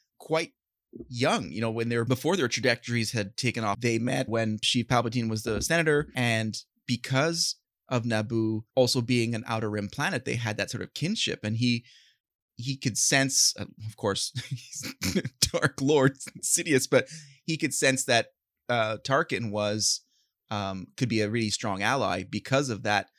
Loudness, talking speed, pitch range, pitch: -27 LUFS, 165 wpm, 110-135 Hz, 120 Hz